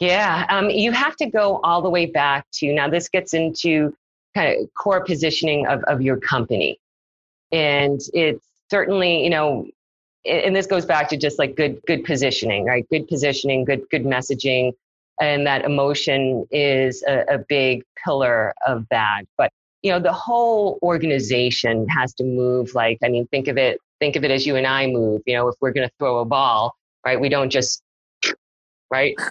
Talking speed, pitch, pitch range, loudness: 185 wpm, 140 Hz, 130-165 Hz, -20 LUFS